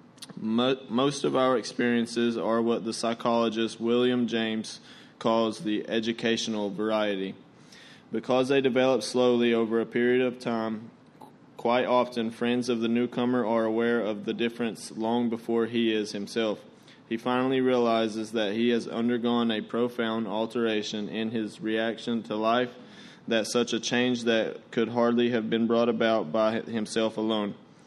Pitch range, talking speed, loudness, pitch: 110-120 Hz, 145 wpm, -27 LUFS, 115 Hz